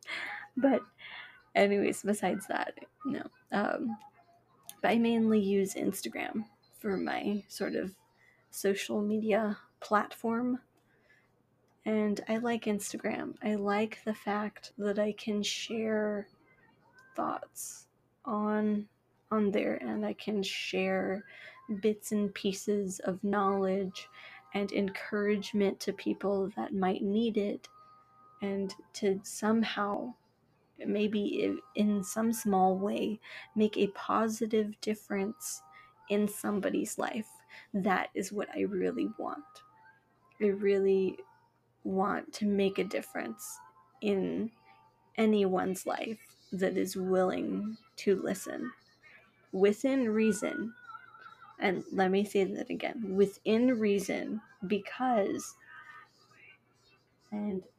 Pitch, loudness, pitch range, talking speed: 205 Hz, -32 LUFS, 195-220 Hz, 105 wpm